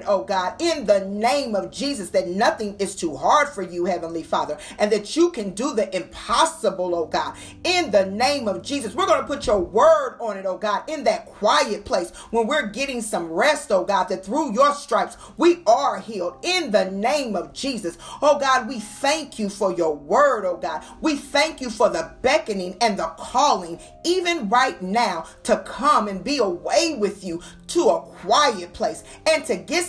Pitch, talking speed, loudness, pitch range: 235 Hz, 200 wpm, -22 LUFS, 195-295 Hz